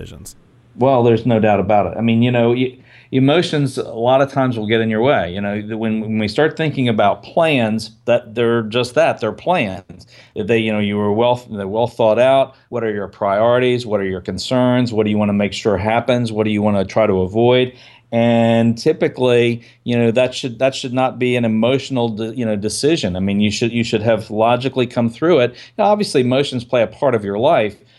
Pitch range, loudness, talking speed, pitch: 110-125 Hz, -17 LUFS, 225 wpm, 115 Hz